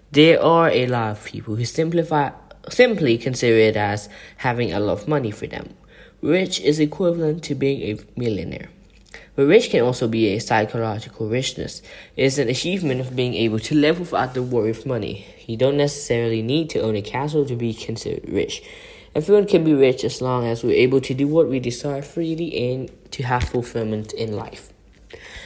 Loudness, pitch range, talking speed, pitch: -20 LUFS, 115-150 Hz, 190 wpm, 130 Hz